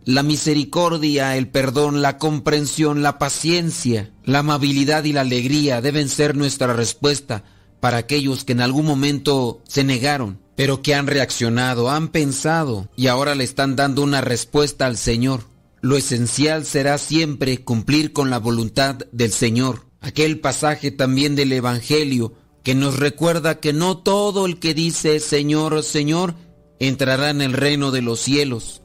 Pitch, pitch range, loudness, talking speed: 140 Hz, 130-150 Hz, -19 LUFS, 150 wpm